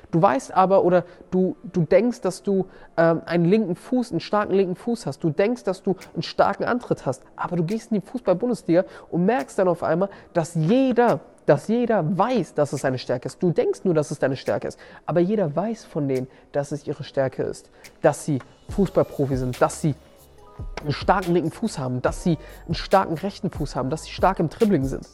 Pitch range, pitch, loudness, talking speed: 155-200 Hz, 175 Hz, -23 LUFS, 210 wpm